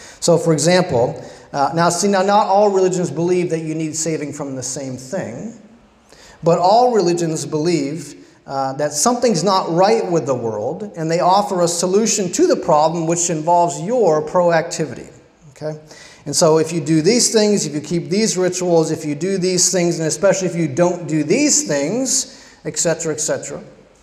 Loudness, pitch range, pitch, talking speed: -17 LUFS, 155-185 Hz, 170 Hz, 180 wpm